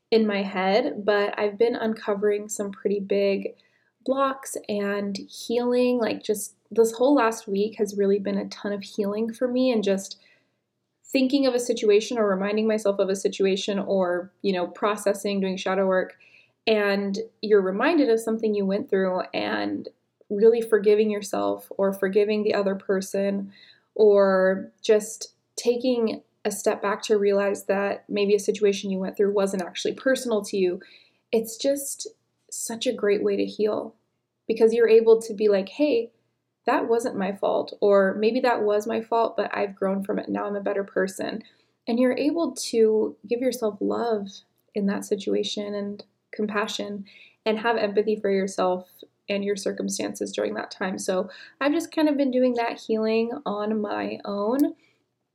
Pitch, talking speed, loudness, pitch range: 210 Hz, 165 wpm, -24 LUFS, 200-230 Hz